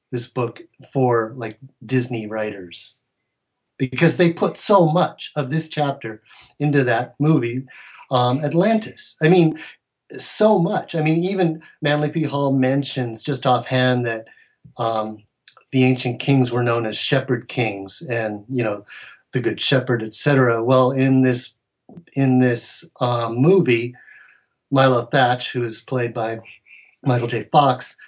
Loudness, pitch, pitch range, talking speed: -20 LUFS, 130 Hz, 120-145 Hz, 140 wpm